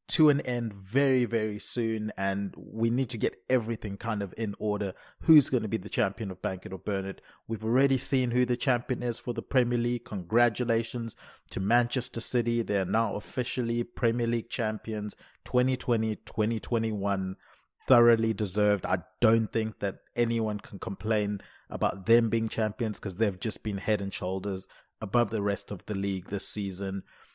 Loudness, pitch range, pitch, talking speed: -29 LUFS, 100-120 Hz, 110 Hz, 170 wpm